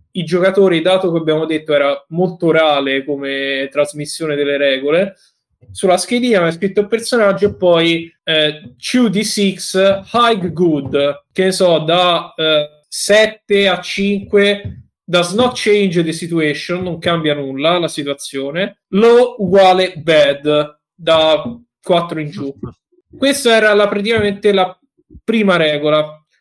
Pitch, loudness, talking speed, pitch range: 175 Hz, -14 LUFS, 135 wpm, 150-200 Hz